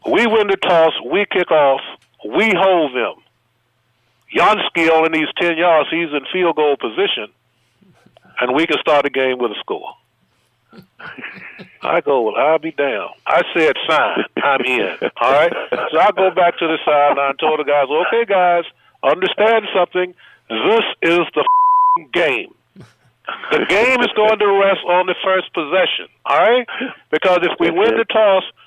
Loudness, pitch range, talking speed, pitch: -15 LUFS, 160-225 Hz, 165 wpm, 180 Hz